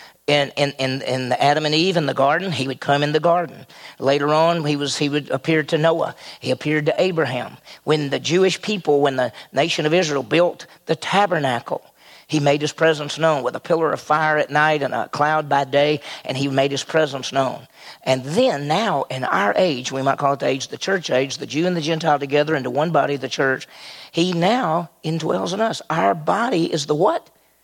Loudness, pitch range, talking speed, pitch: -20 LUFS, 135-165 Hz, 220 wpm, 150 Hz